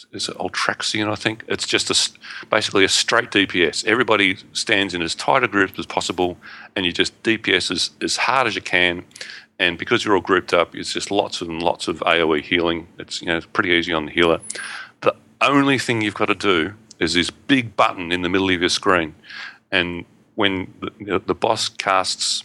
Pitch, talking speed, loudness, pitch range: 95 Hz, 210 wpm, -19 LUFS, 85-105 Hz